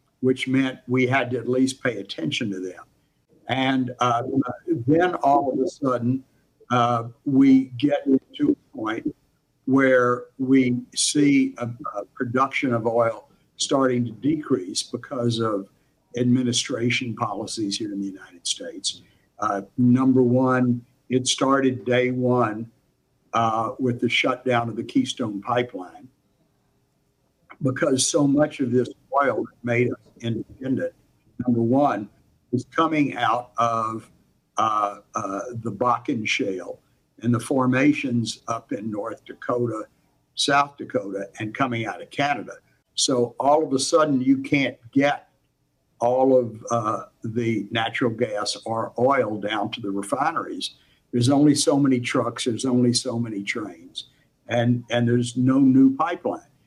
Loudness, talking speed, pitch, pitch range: -23 LUFS, 140 wpm, 125 Hz, 115-135 Hz